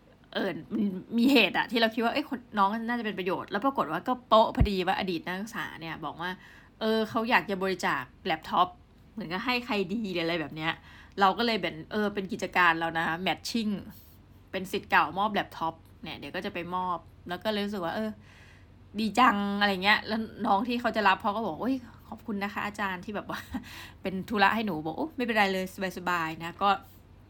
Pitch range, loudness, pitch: 175-220 Hz, -29 LUFS, 195 Hz